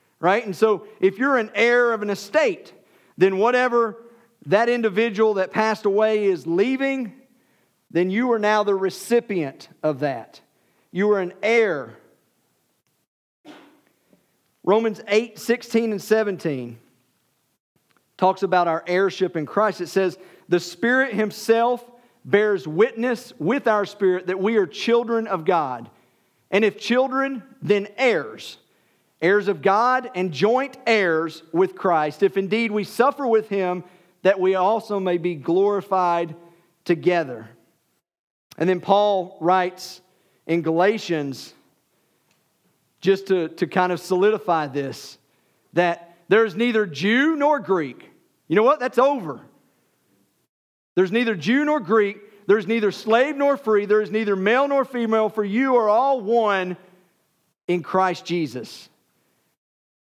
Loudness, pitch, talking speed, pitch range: -21 LUFS, 205 Hz, 130 wpm, 180-230 Hz